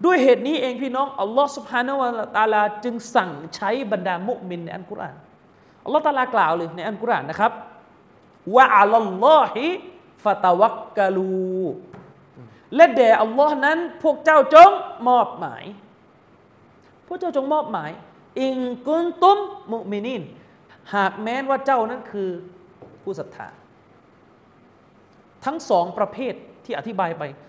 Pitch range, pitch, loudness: 205-285 Hz, 245 Hz, -19 LUFS